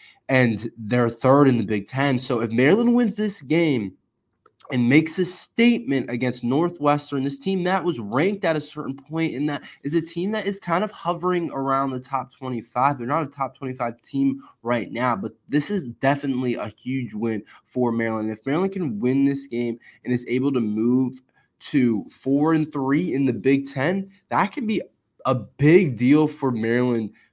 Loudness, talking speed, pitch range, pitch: -23 LUFS, 190 wpm, 125-165 Hz, 135 Hz